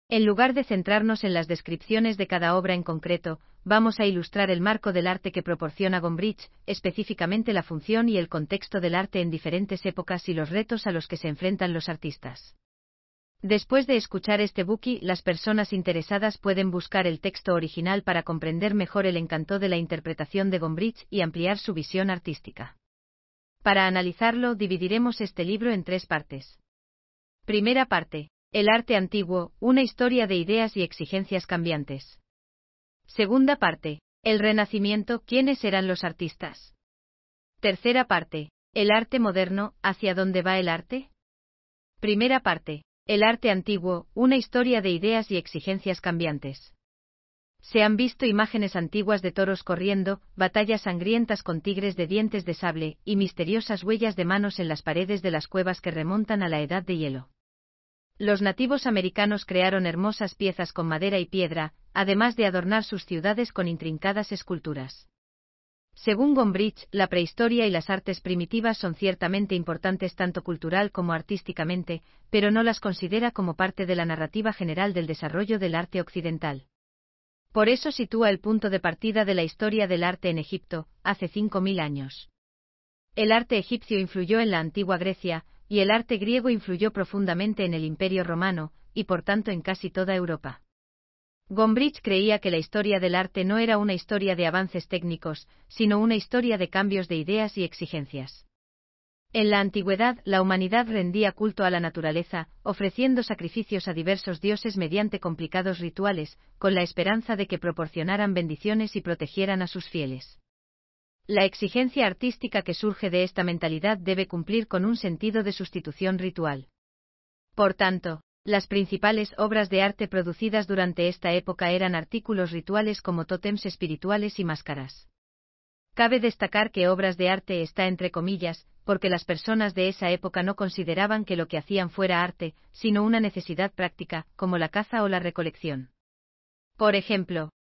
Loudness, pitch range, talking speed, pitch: -26 LUFS, 170-210 Hz, 160 wpm, 190 Hz